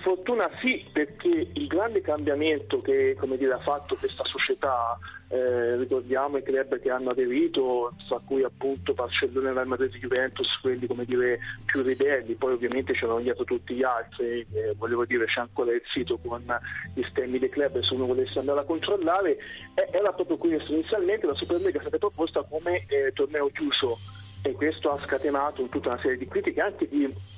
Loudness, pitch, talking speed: -27 LUFS, 140 Hz, 180 wpm